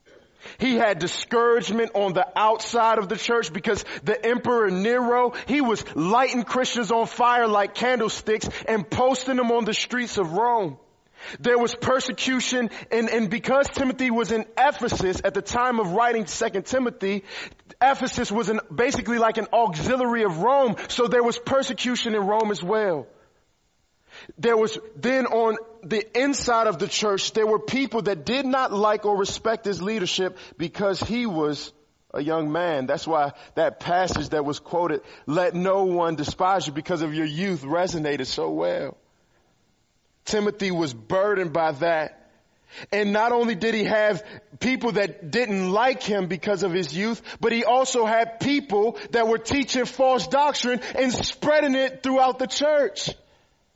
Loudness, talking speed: -23 LUFS, 160 wpm